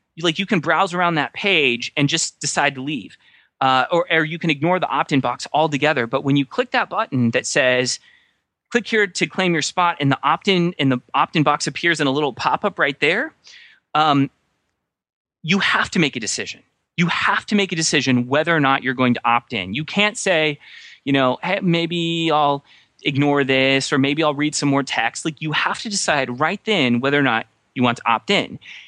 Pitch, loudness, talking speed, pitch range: 150 Hz, -19 LUFS, 220 wpm, 135-175 Hz